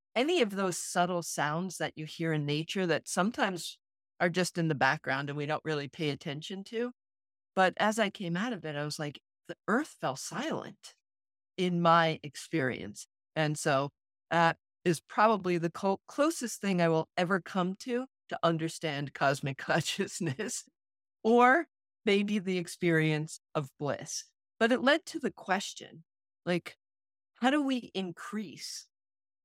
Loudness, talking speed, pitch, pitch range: -31 LUFS, 155 wpm, 175 Hz, 155-205 Hz